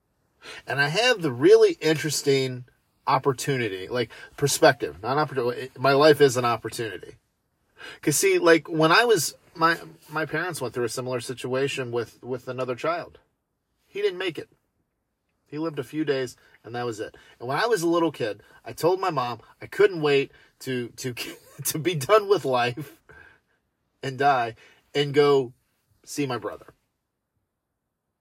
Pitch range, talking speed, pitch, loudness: 125-155 Hz, 160 wpm, 140 Hz, -24 LUFS